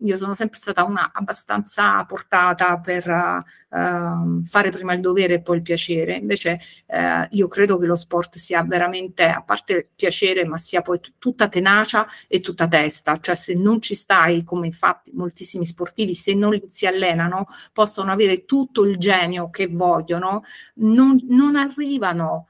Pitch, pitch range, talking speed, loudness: 180 Hz, 175-205 Hz, 165 wpm, -18 LUFS